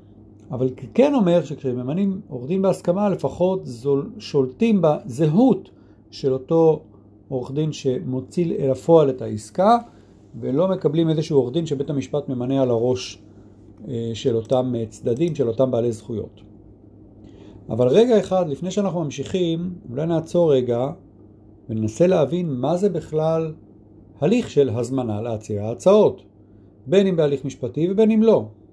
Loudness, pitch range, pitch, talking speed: -21 LUFS, 110-170 Hz, 135 Hz, 130 wpm